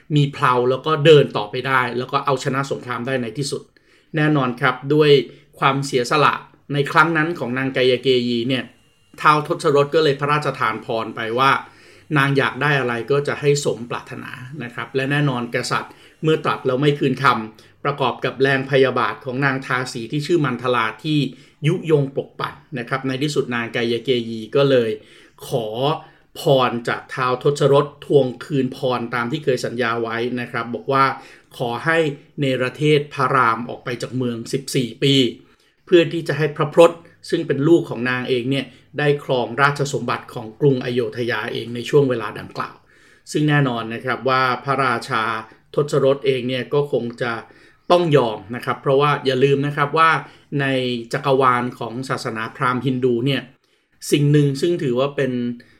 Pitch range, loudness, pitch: 125-145 Hz, -19 LUFS, 135 Hz